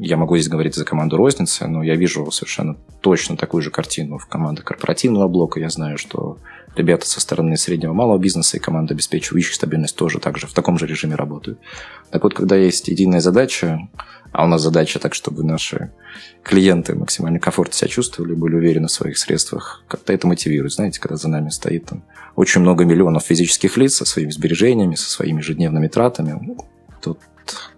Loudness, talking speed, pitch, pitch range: -17 LUFS, 185 wpm, 80 Hz, 80-90 Hz